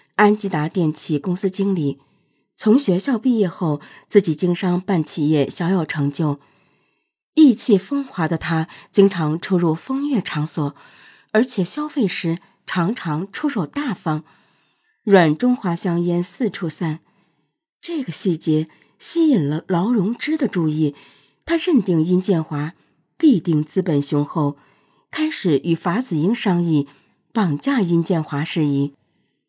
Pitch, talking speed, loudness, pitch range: 175 Hz, 200 characters per minute, -20 LUFS, 155-215 Hz